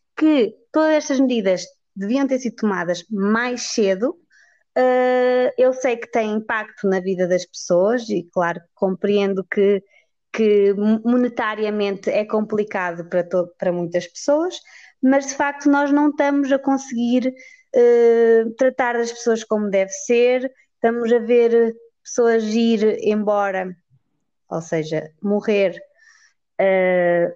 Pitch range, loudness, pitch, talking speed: 195-255 Hz, -19 LUFS, 225 Hz, 125 wpm